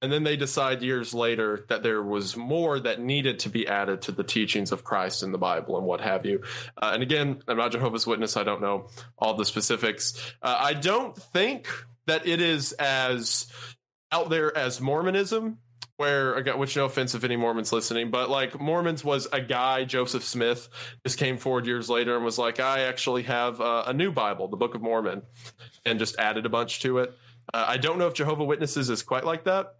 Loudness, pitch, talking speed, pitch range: -26 LUFS, 125 Hz, 215 wpm, 115-140 Hz